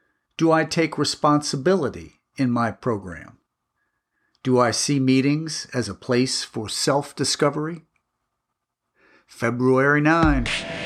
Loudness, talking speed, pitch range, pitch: -21 LUFS, 105 wpm, 120-150 Hz, 135 Hz